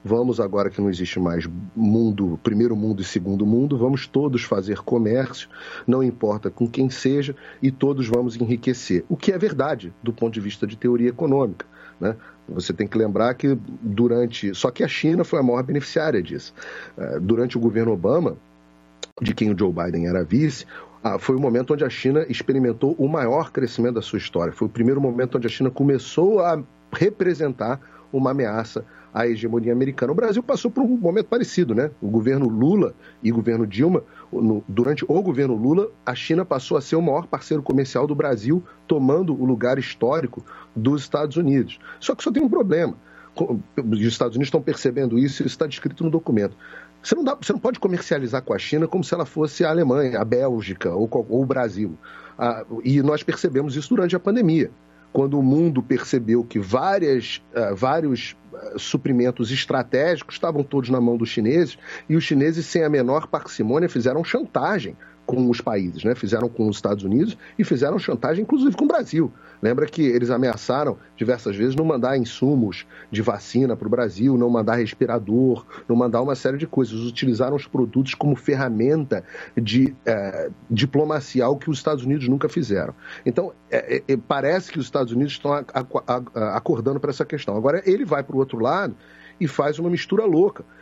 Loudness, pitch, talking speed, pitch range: -22 LUFS, 130 Hz, 190 wpm, 115-150 Hz